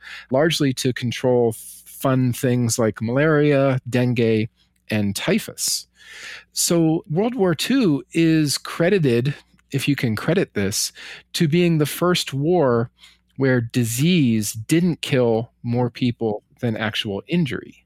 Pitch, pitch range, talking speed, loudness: 130 Hz, 115-160 Hz, 120 wpm, -20 LUFS